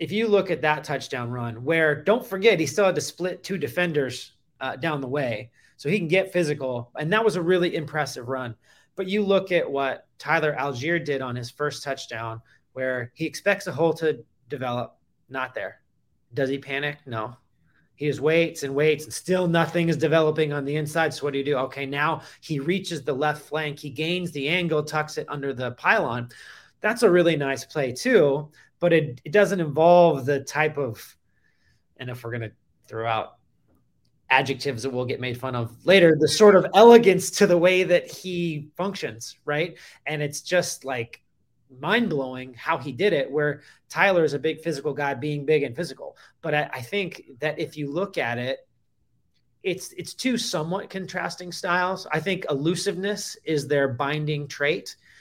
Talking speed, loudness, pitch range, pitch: 190 wpm, -24 LUFS, 135-175 Hz, 150 Hz